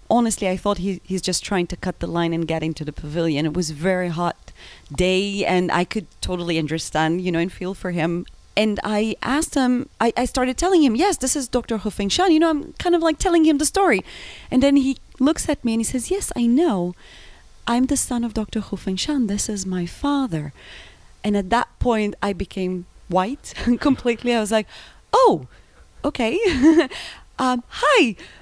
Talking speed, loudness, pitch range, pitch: 205 wpm, -21 LUFS, 180-270 Hz, 220 Hz